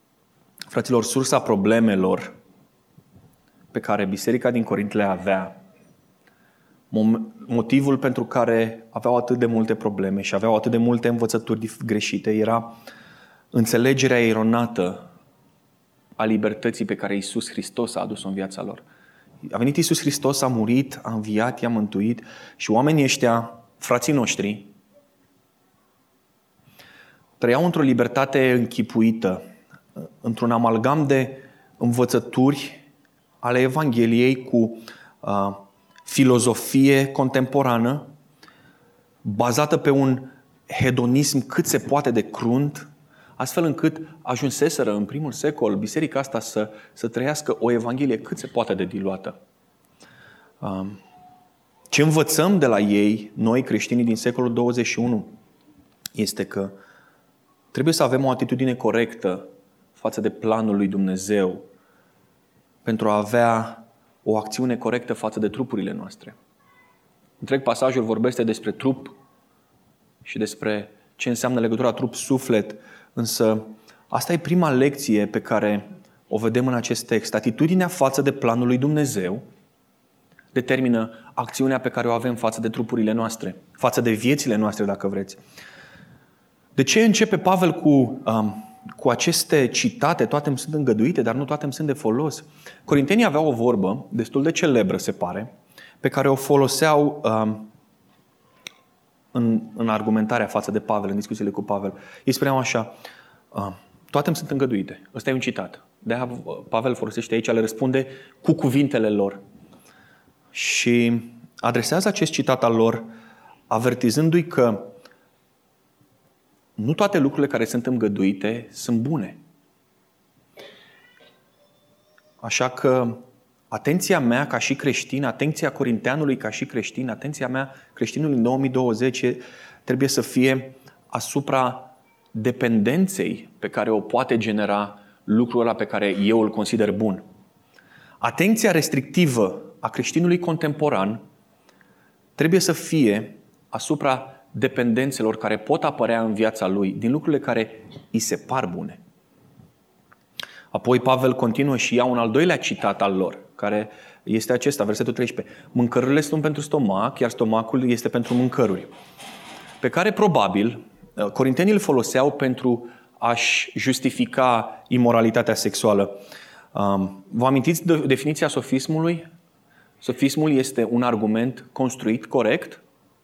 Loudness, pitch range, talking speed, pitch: -22 LUFS, 110-135 Hz, 125 wpm, 120 Hz